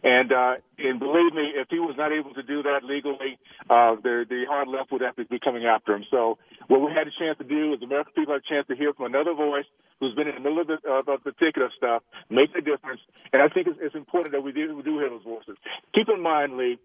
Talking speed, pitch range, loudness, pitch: 275 wpm, 125-150 Hz, -25 LUFS, 140 Hz